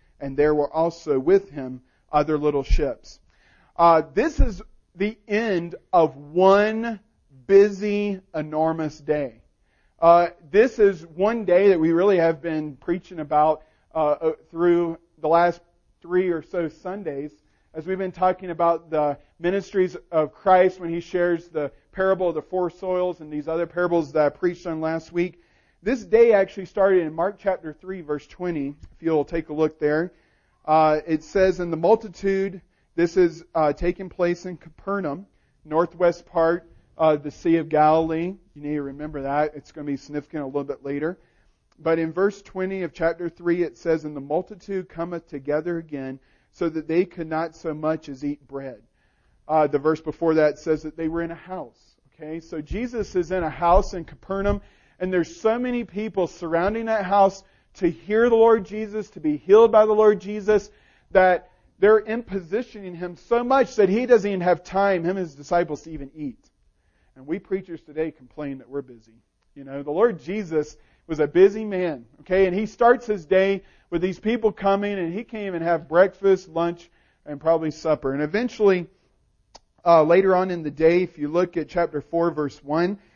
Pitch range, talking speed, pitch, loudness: 155-190 Hz, 185 wpm, 170 Hz, -22 LUFS